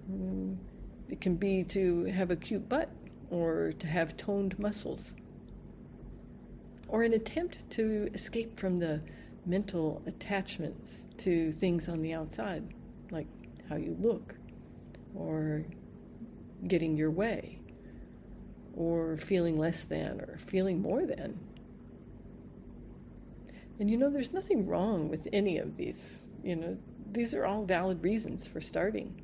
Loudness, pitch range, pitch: -34 LUFS, 160-210 Hz, 185 Hz